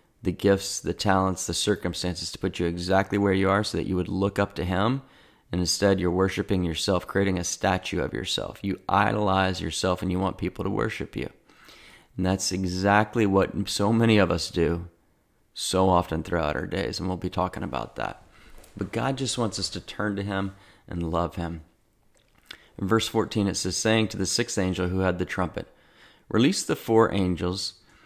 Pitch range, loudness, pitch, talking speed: 90-100 Hz, -26 LUFS, 95 Hz, 195 wpm